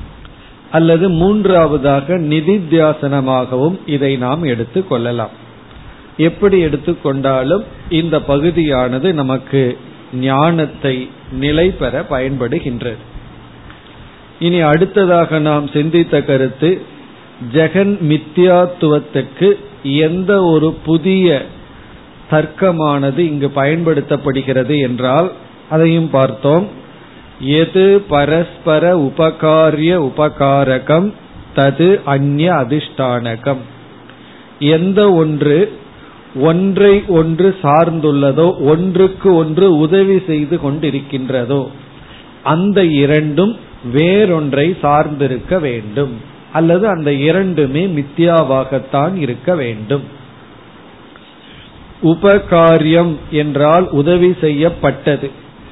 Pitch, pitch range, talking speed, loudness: 155 Hz, 140-170 Hz, 70 wpm, -13 LUFS